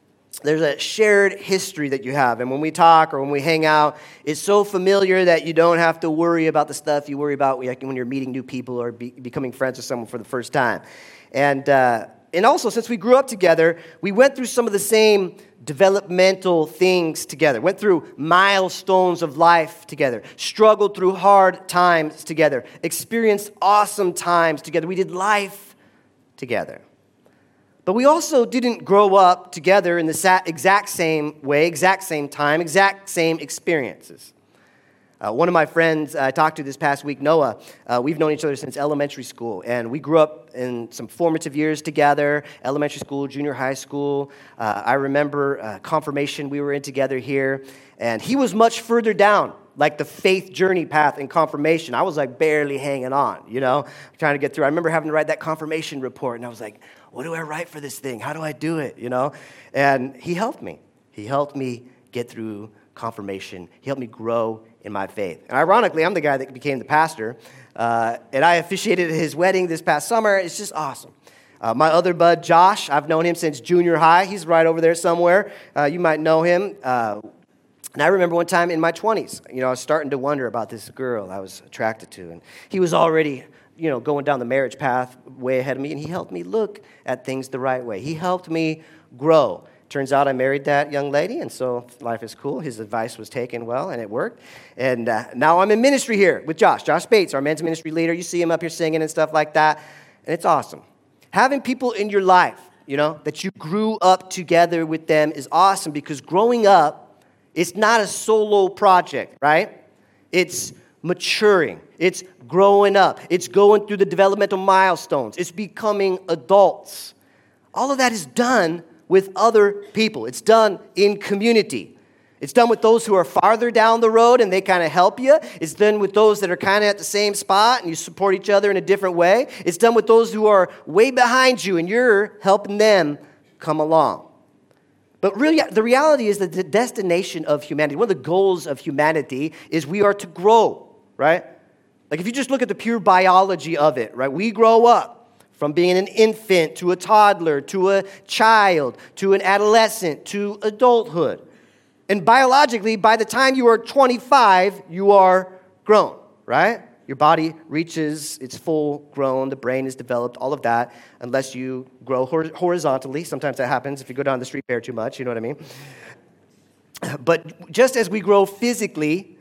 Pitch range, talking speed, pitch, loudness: 140-195 Hz, 200 wpm, 165 Hz, -19 LUFS